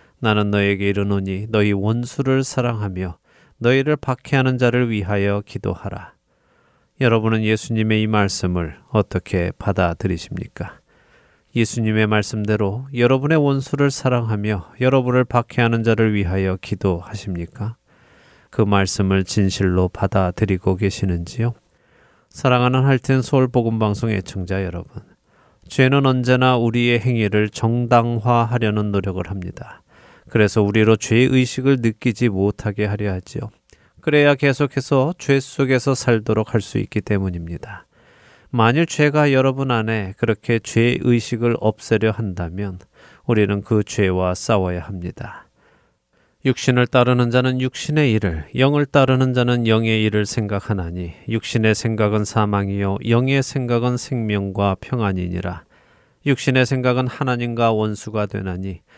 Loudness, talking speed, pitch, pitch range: -19 LUFS, 305 characters per minute, 110 Hz, 100-125 Hz